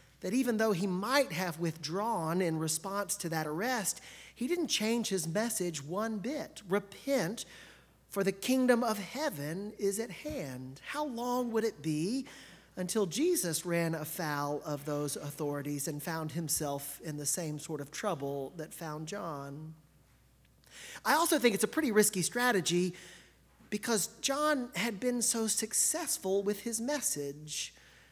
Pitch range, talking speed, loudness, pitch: 155-235 Hz, 145 wpm, -33 LUFS, 195 Hz